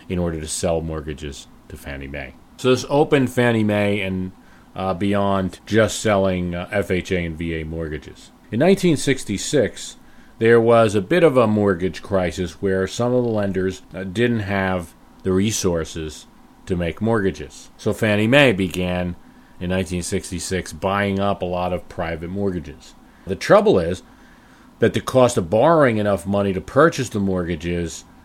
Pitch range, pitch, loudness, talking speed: 90-105 Hz, 95 Hz, -20 LUFS, 155 wpm